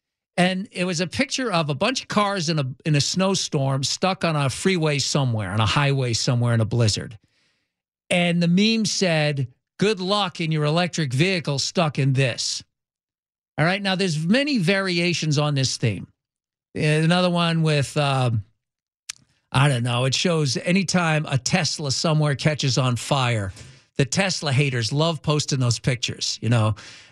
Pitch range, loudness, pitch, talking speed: 130-180 Hz, -22 LUFS, 150 Hz, 165 wpm